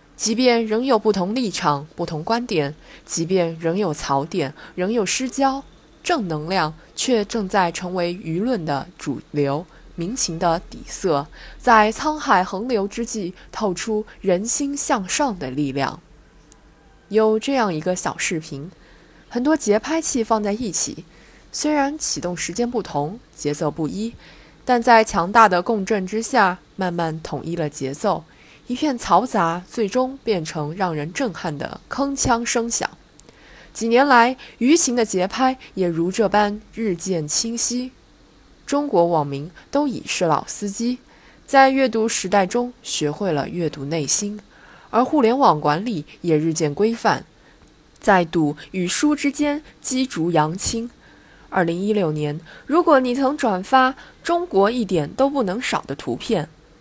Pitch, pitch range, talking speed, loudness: 210 Hz, 165-245 Hz, 210 characters per minute, -20 LUFS